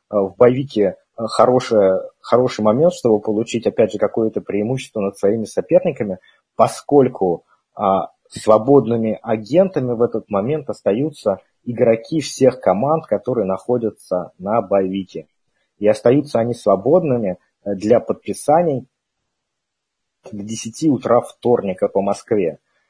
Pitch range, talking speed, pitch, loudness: 105-135 Hz, 105 wpm, 115 Hz, -18 LUFS